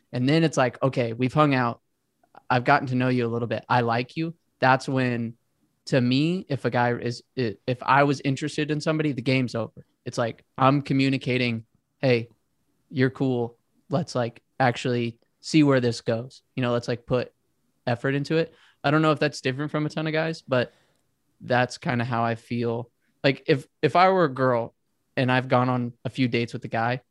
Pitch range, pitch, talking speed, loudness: 120-145 Hz, 130 Hz, 205 wpm, -25 LUFS